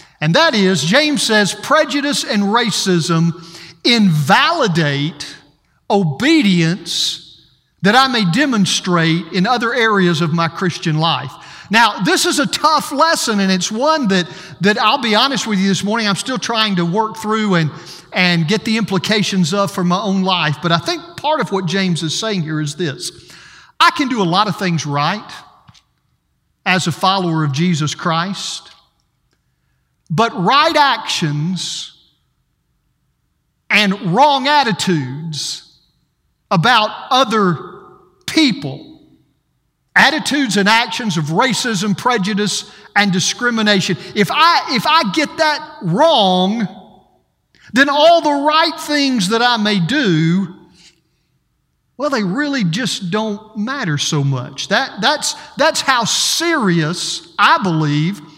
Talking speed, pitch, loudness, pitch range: 135 wpm, 195 Hz, -15 LUFS, 170-235 Hz